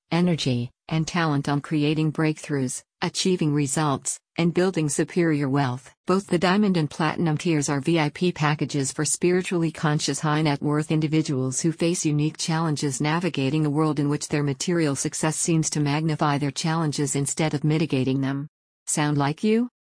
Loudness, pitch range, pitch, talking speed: -24 LUFS, 145-165 Hz, 155 Hz, 155 wpm